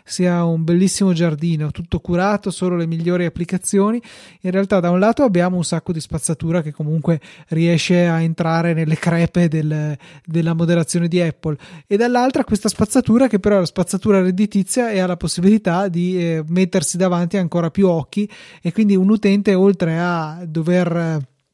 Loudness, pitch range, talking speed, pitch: -18 LUFS, 165-195 Hz, 170 wpm, 175 Hz